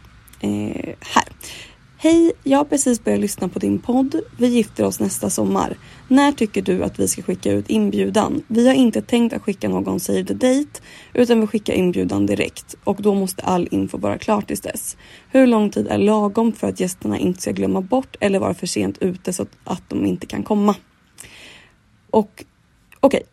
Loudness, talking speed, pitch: -19 LUFS, 195 wpm, 205 Hz